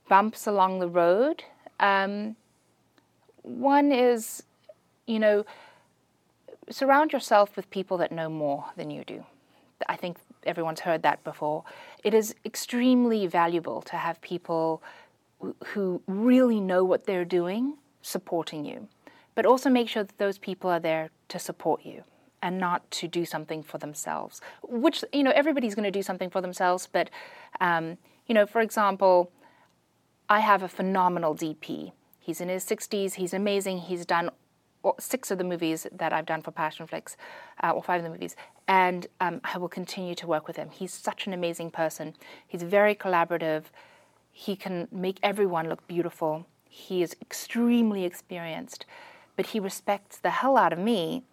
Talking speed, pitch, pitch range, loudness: 165 wpm, 185 Hz, 170-215 Hz, -27 LUFS